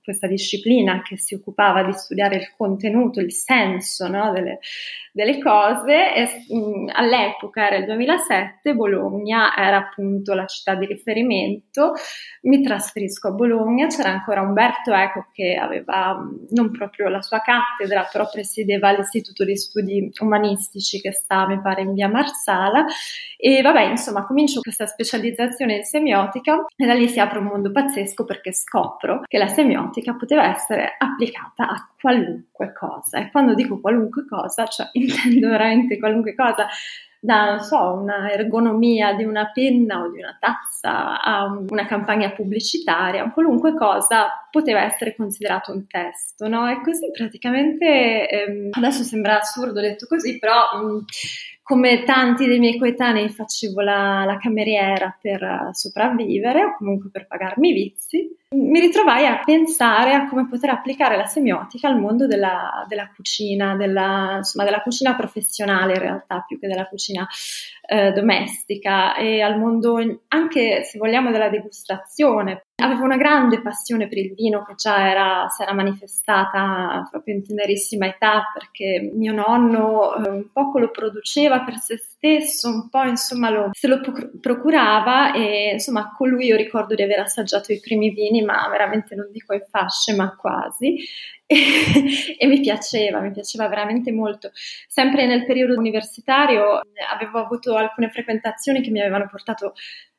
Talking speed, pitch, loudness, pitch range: 150 wpm, 220 Hz, -19 LUFS, 200-255 Hz